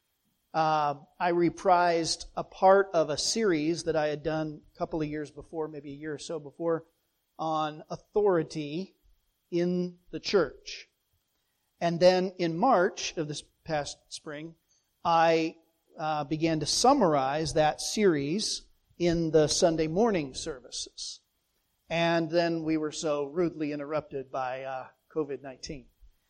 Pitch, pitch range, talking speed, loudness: 160 Hz, 150-170 Hz, 135 wpm, -28 LUFS